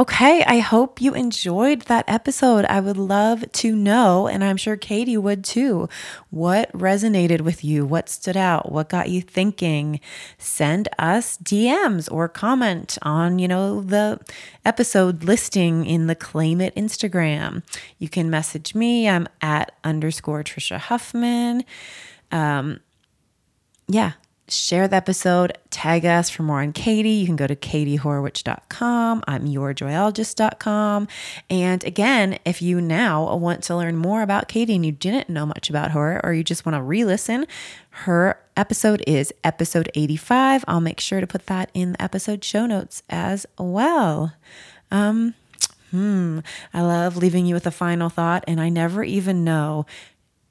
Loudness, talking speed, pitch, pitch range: -21 LUFS, 155 wpm, 185 Hz, 165-215 Hz